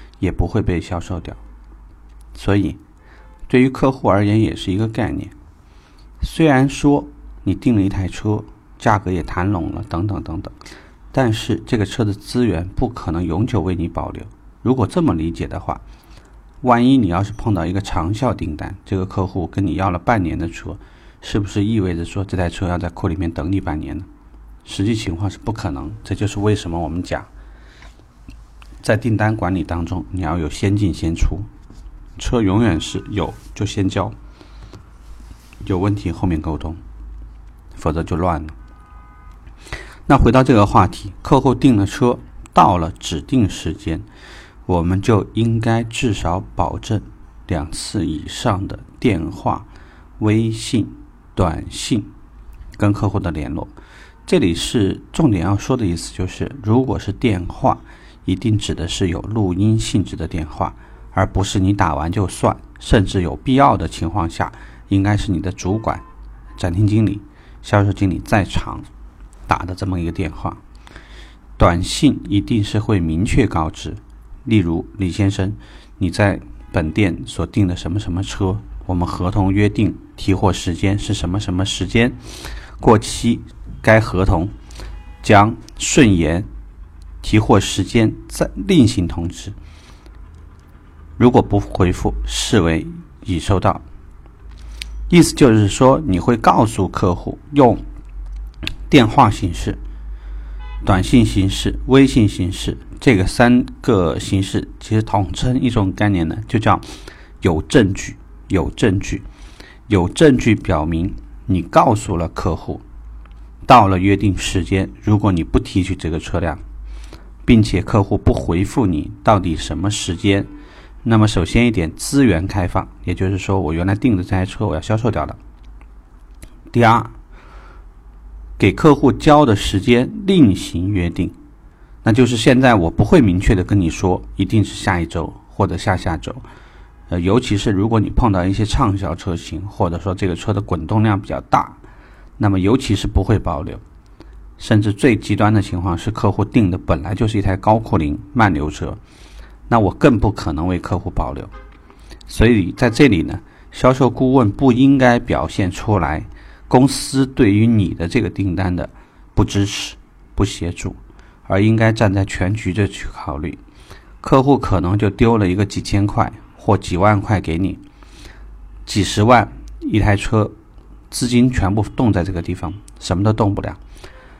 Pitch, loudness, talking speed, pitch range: 95 Hz, -17 LUFS, 230 characters per minute, 85-105 Hz